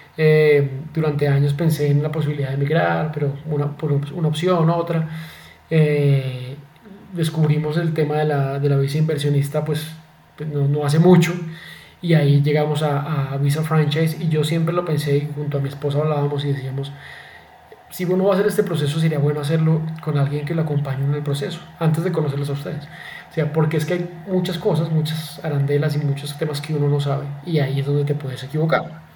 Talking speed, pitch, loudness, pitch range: 200 wpm, 150 Hz, -20 LUFS, 145-160 Hz